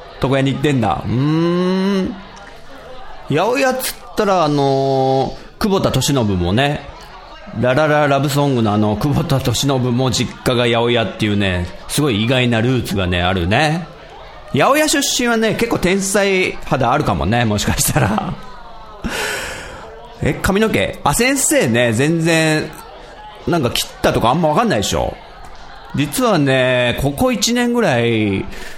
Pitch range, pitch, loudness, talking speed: 120-185 Hz, 140 Hz, -16 LUFS, 255 characters per minute